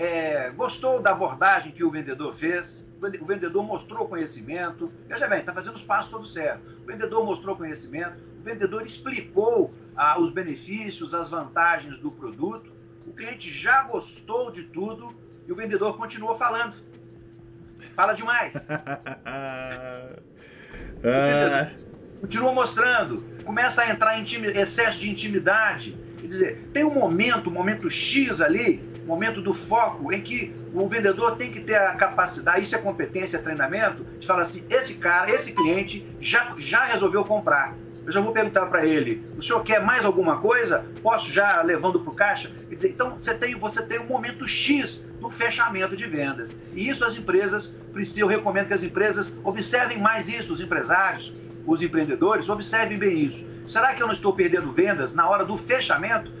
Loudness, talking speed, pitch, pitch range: -24 LUFS, 170 wpm, 200 Hz, 165-240 Hz